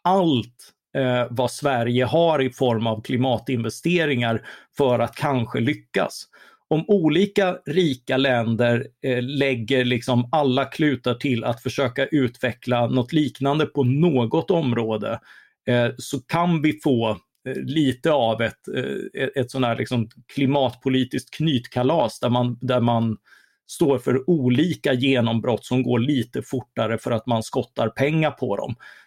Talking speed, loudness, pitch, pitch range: 135 wpm, -22 LUFS, 130 Hz, 120-145 Hz